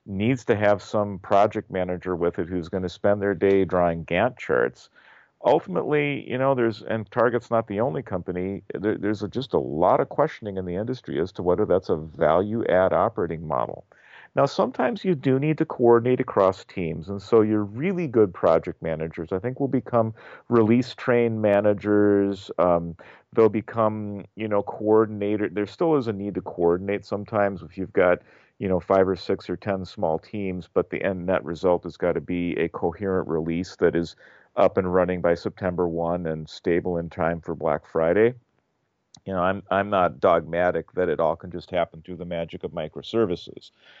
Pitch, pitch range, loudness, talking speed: 100 Hz, 90-110 Hz, -24 LUFS, 190 wpm